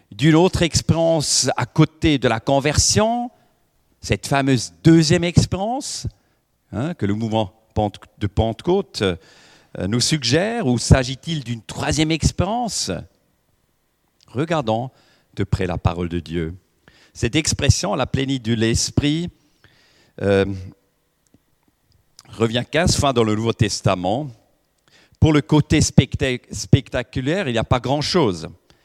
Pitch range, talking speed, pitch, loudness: 105-150 Hz, 115 wpm, 125 Hz, -19 LUFS